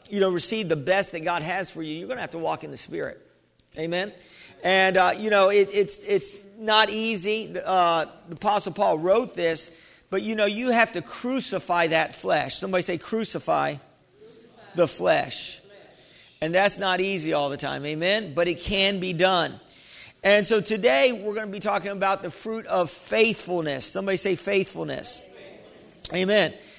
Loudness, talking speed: -24 LUFS, 175 wpm